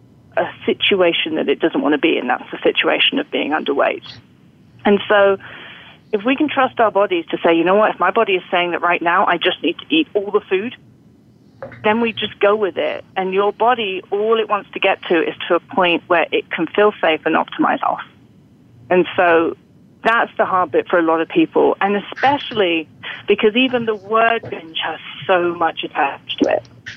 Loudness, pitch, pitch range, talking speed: -17 LUFS, 205 Hz, 175-225 Hz, 210 wpm